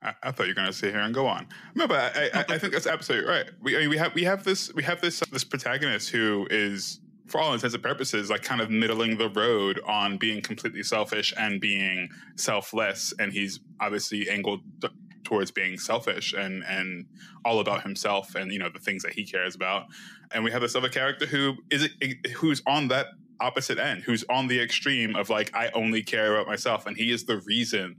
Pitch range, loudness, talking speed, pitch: 100-130 Hz, -27 LUFS, 225 wpm, 110 Hz